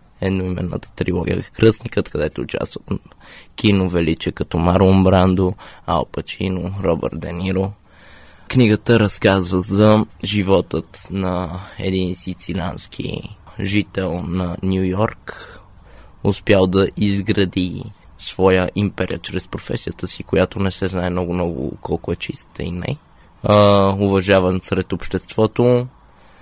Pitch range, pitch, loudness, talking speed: 90-100 Hz, 95 Hz, -19 LUFS, 105 wpm